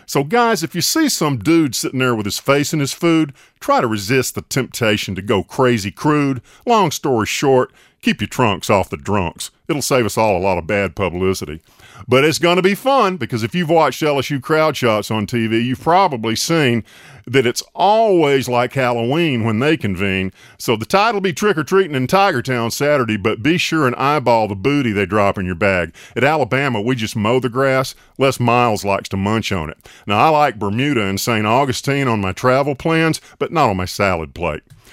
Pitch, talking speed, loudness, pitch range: 125 Hz, 210 wpm, -17 LUFS, 105-150 Hz